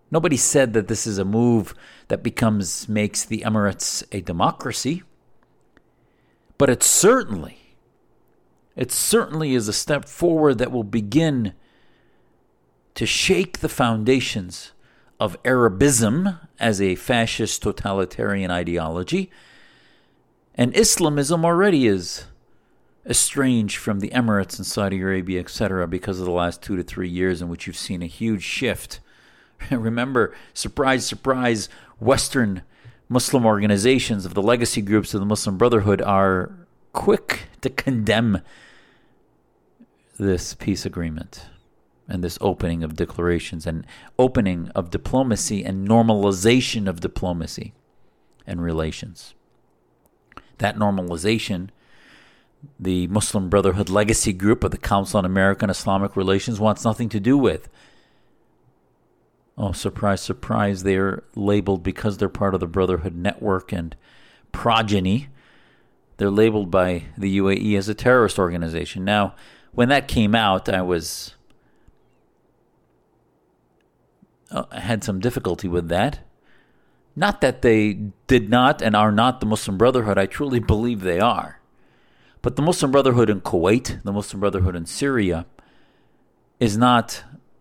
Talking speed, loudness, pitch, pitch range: 125 wpm, -21 LUFS, 105 Hz, 95-120 Hz